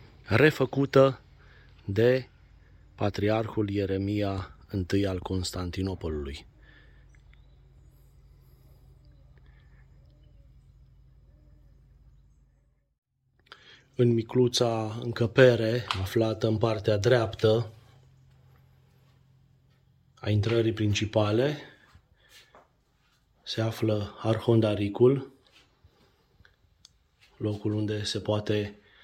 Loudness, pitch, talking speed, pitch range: -27 LUFS, 110 Hz, 50 wpm, 100-125 Hz